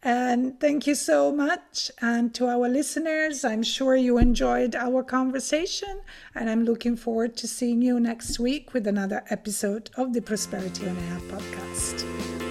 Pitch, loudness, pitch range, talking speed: 245 Hz, -26 LUFS, 220-265 Hz, 160 wpm